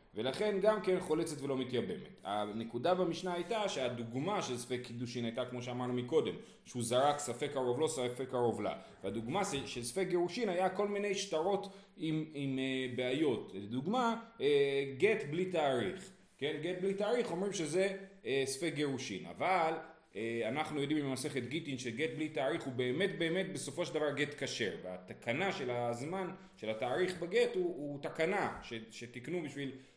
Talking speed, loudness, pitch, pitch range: 150 wpm, -36 LUFS, 150 Hz, 125-185 Hz